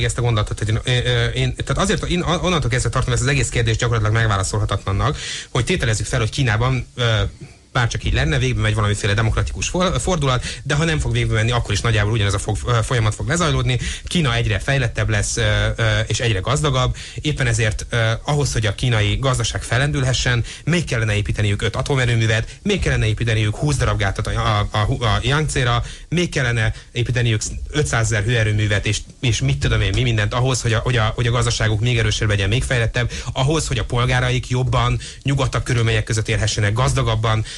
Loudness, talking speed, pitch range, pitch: -19 LUFS, 185 wpm, 110-130 Hz, 120 Hz